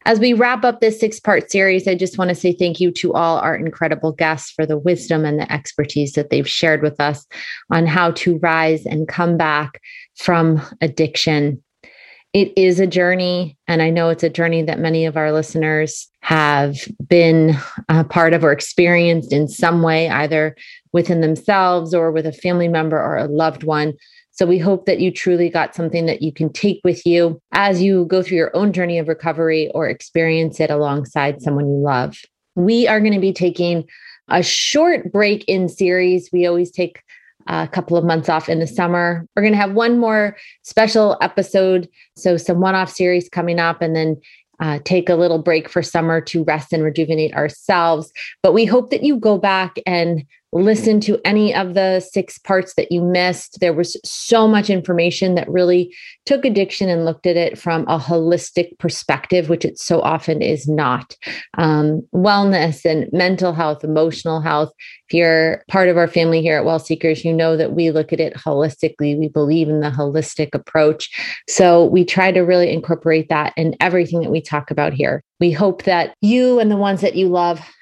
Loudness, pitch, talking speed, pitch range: -16 LUFS, 170 Hz, 195 wpm, 160-185 Hz